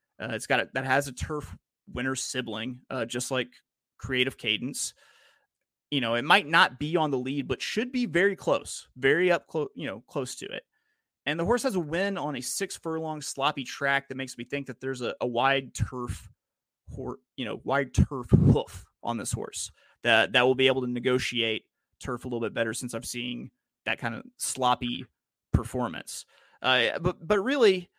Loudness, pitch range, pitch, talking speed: -28 LUFS, 120-155 Hz, 130 Hz, 195 wpm